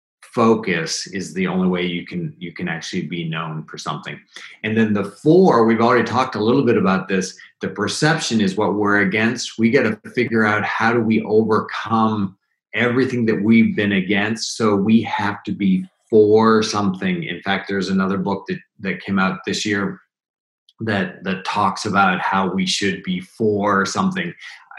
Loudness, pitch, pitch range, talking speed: -19 LUFS, 105 Hz, 95-115 Hz, 180 wpm